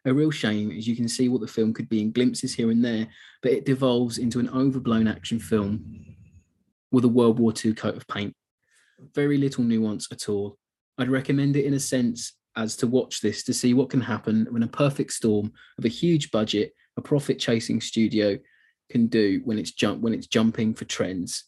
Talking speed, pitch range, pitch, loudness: 210 wpm, 110-130 Hz, 115 Hz, -25 LUFS